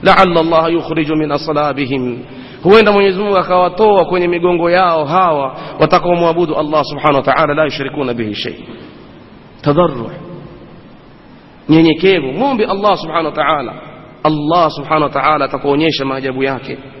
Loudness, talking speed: -13 LUFS, 125 wpm